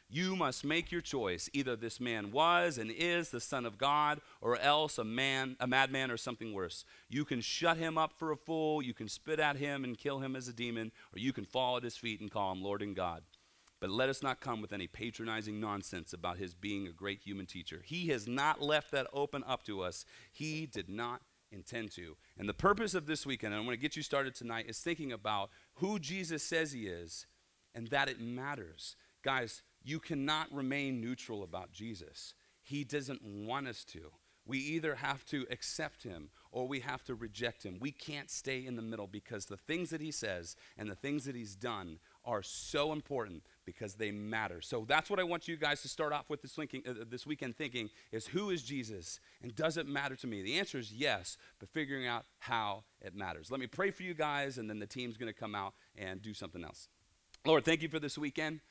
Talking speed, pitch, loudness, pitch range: 225 wpm, 125 Hz, -38 LUFS, 110-150 Hz